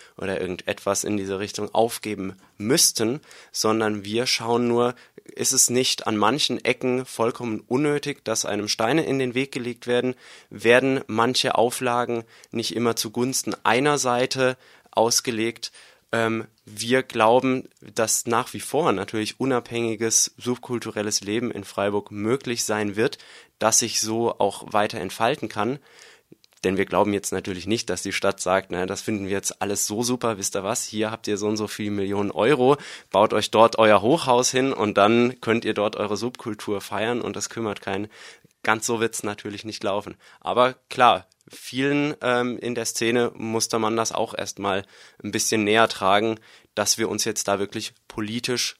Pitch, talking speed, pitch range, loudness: 115 Hz, 170 wpm, 105-120 Hz, -23 LUFS